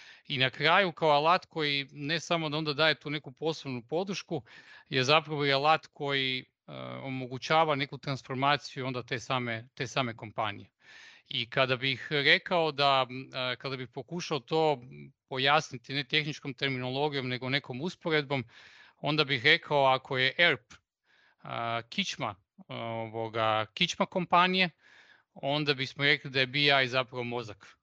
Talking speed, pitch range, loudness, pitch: 135 wpm, 130-155 Hz, -29 LUFS, 140 Hz